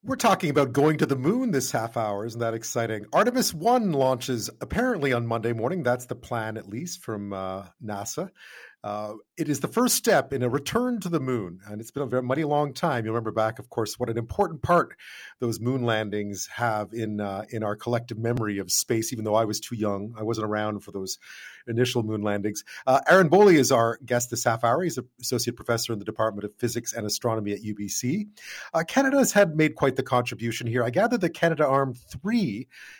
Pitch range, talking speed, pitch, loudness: 110-150 Hz, 220 wpm, 120 Hz, -25 LUFS